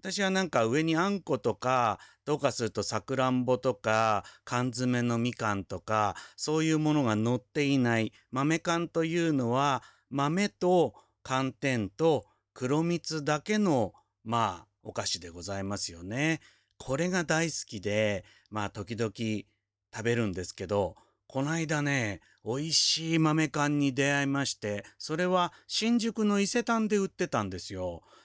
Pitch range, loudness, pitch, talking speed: 110-160 Hz, -29 LUFS, 130 Hz, 280 characters per minute